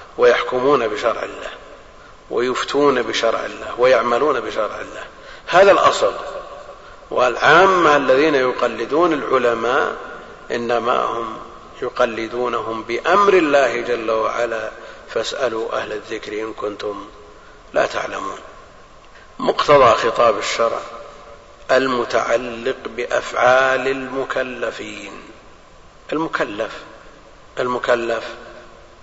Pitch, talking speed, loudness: 130 Hz, 75 wpm, -18 LUFS